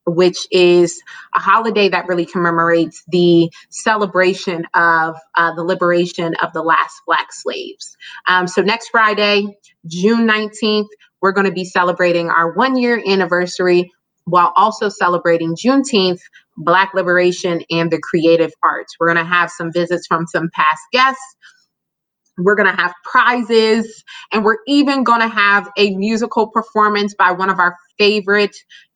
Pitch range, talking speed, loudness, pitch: 175-215 Hz, 150 wpm, -15 LUFS, 185 Hz